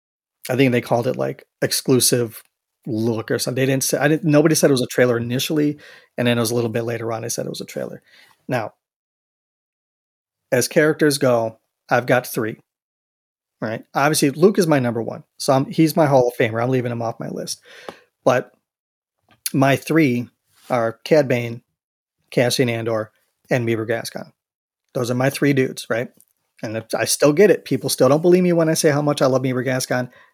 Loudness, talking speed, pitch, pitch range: -19 LUFS, 200 wpm, 130 Hz, 120-150 Hz